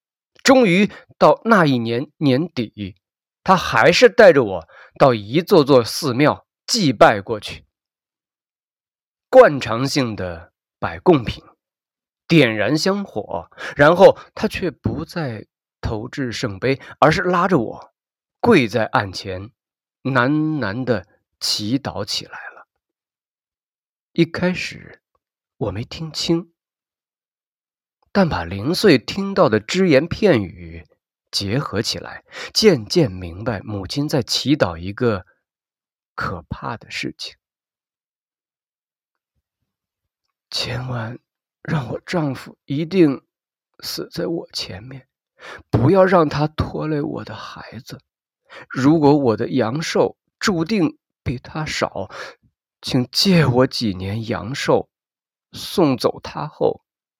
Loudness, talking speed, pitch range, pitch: -18 LUFS, 150 characters per minute, 110-165 Hz, 130 Hz